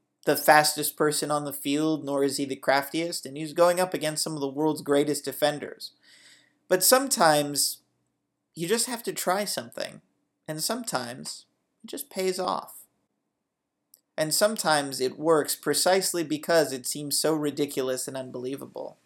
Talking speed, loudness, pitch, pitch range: 150 wpm, -25 LUFS, 150 Hz, 140-165 Hz